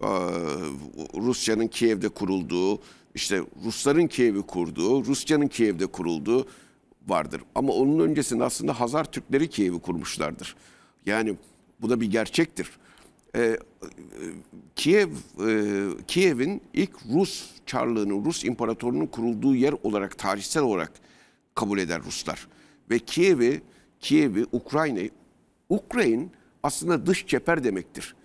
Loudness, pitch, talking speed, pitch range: -26 LUFS, 115 Hz, 105 wpm, 100-135 Hz